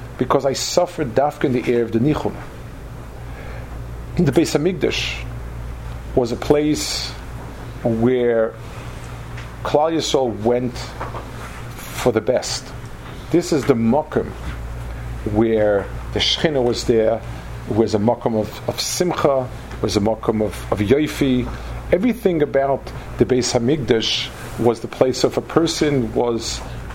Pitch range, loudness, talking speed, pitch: 110-130 Hz, -19 LUFS, 125 wpm, 120 Hz